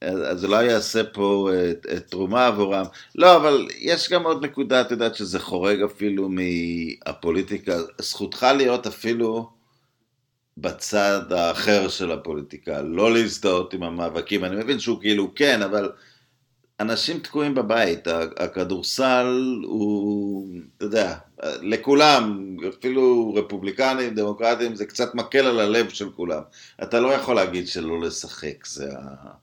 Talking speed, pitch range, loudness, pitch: 130 wpm, 95-125 Hz, -22 LUFS, 110 Hz